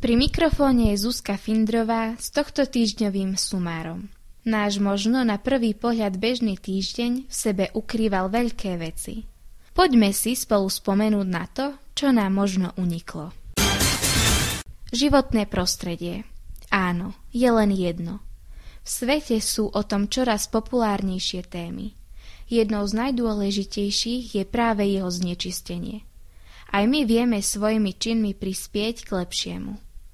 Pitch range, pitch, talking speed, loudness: 190-235 Hz, 210 Hz, 120 wpm, -23 LUFS